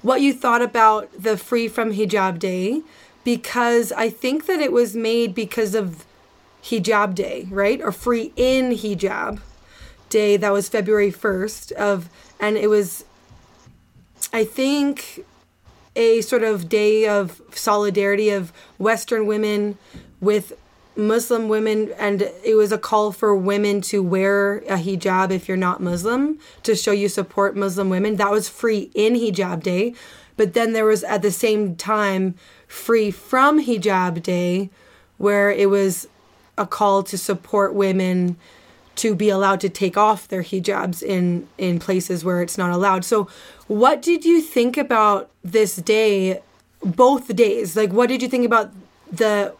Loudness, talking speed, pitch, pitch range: -20 LUFS, 155 wpm, 210 Hz, 195-225 Hz